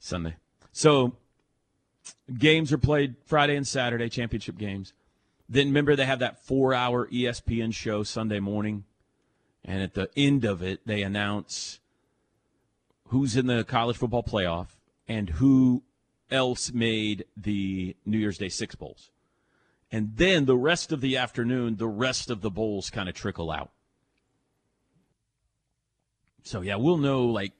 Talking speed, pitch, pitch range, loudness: 145 wpm, 120 Hz, 105-130 Hz, -26 LUFS